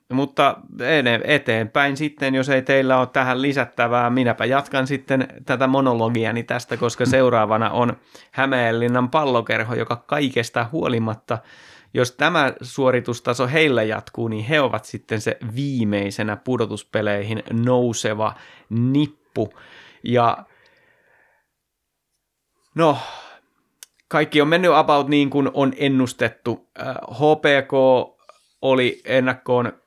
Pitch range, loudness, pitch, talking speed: 115-140 Hz, -20 LUFS, 130 Hz, 100 wpm